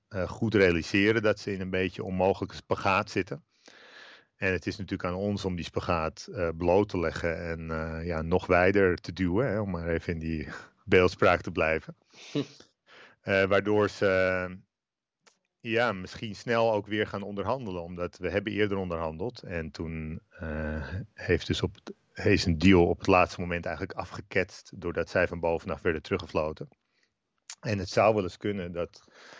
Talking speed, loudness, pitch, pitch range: 175 wpm, -29 LUFS, 95 Hz, 85-100 Hz